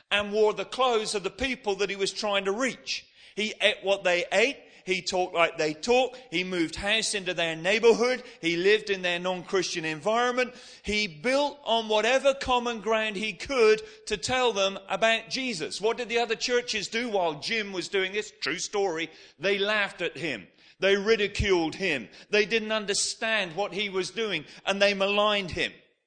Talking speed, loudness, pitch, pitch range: 180 wpm, -26 LUFS, 205 Hz, 190-225 Hz